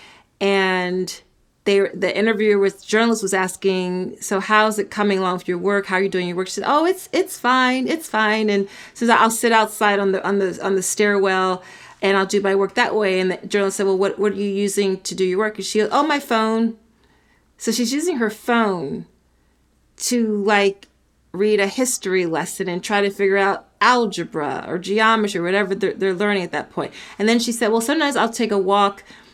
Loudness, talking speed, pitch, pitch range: -19 LUFS, 220 wpm, 200 Hz, 190-220 Hz